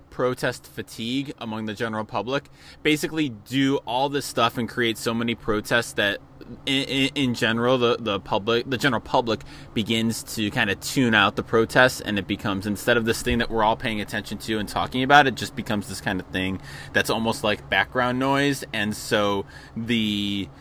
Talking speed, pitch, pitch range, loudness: 190 wpm, 115 Hz, 105-130 Hz, -23 LUFS